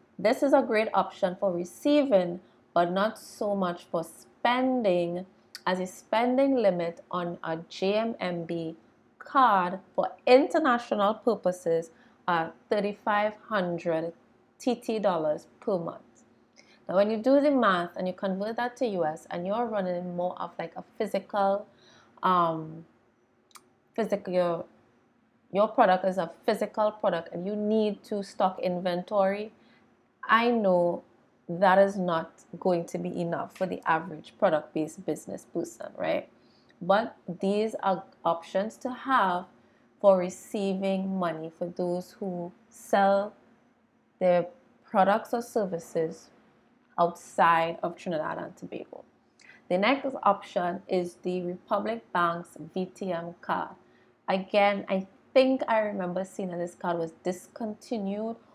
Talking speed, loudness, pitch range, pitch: 130 wpm, -28 LUFS, 175-220 Hz, 190 Hz